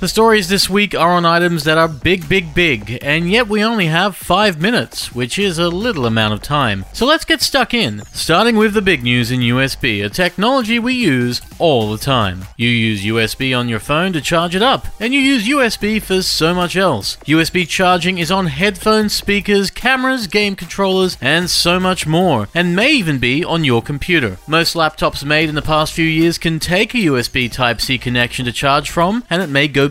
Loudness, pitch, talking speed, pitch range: -14 LUFS, 170 Hz, 210 wpm, 135-200 Hz